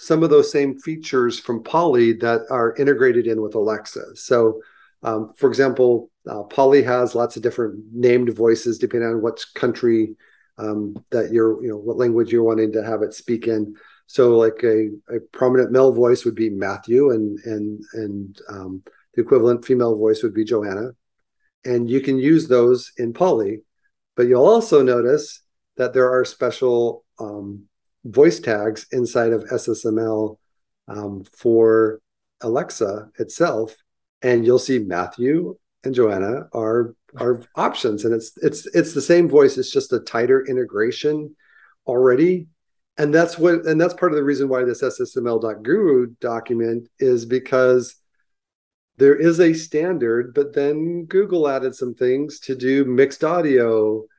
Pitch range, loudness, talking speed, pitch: 115-145 Hz, -19 LUFS, 155 wpm, 120 Hz